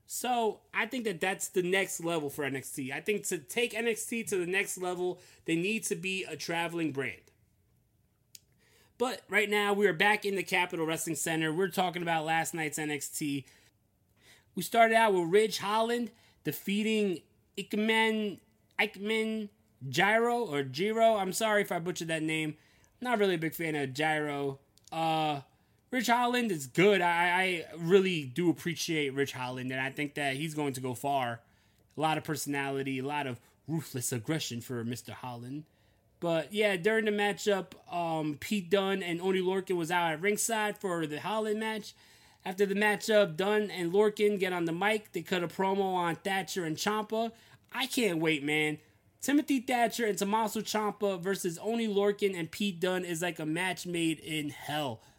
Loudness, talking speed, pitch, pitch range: -31 LUFS, 175 wpm, 180 Hz, 150-205 Hz